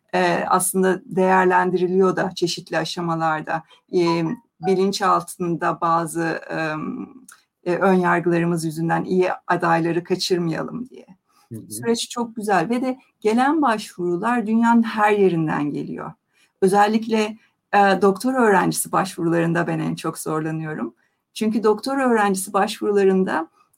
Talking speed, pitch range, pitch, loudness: 95 wpm, 170-210 Hz, 185 Hz, -20 LUFS